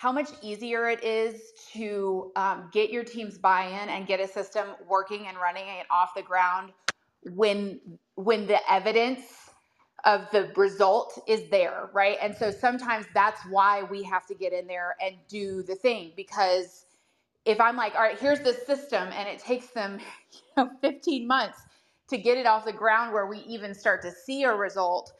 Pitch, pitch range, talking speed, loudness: 205 Hz, 190-230 Hz, 185 wpm, -27 LUFS